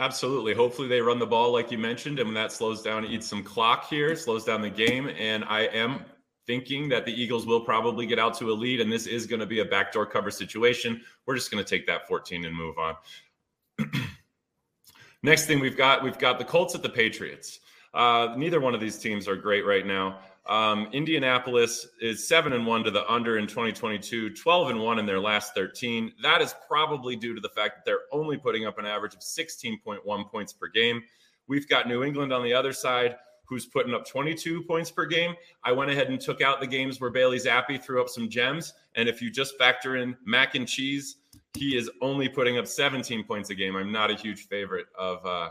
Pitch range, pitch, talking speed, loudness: 110-135 Hz, 120 Hz, 225 wpm, -26 LUFS